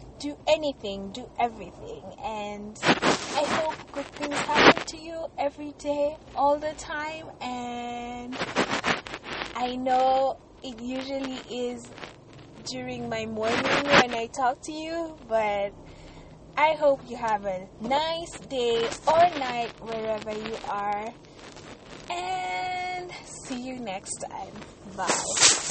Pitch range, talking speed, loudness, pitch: 230-295 Hz, 115 wpm, -27 LUFS, 255 Hz